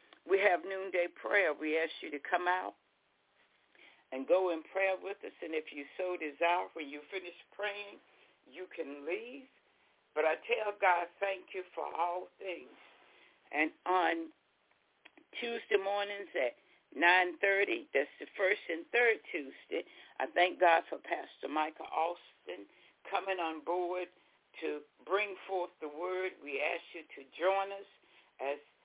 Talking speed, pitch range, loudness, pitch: 150 wpm, 165-195 Hz, -34 LUFS, 180 Hz